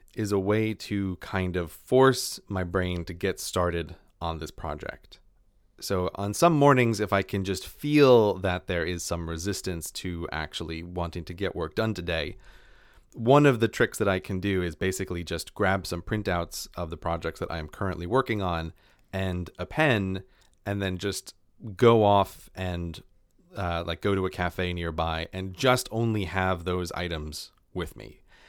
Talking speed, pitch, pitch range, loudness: 175 wpm, 95 Hz, 85-100 Hz, -27 LUFS